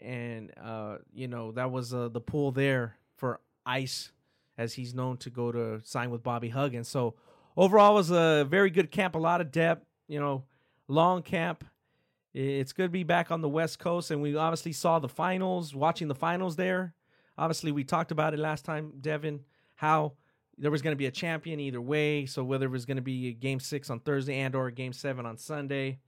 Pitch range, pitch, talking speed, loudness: 130-160 Hz, 145 Hz, 215 wpm, -30 LUFS